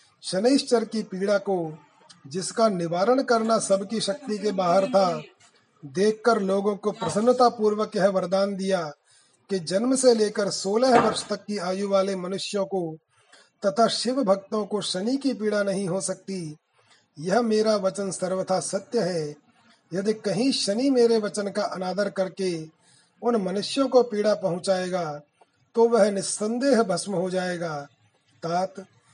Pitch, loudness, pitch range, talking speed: 195 Hz, -24 LUFS, 185-220 Hz, 135 wpm